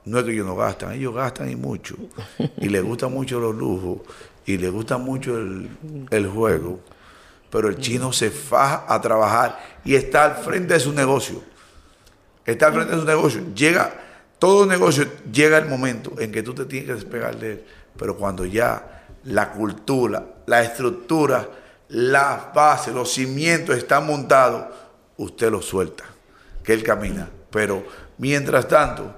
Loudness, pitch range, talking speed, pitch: -20 LUFS, 110-145 Hz, 165 wpm, 125 Hz